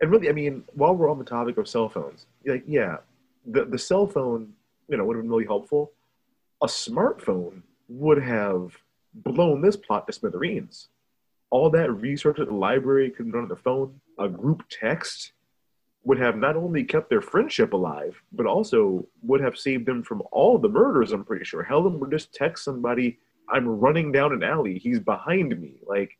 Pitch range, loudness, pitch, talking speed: 115-150 Hz, -24 LUFS, 135 Hz, 190 wpm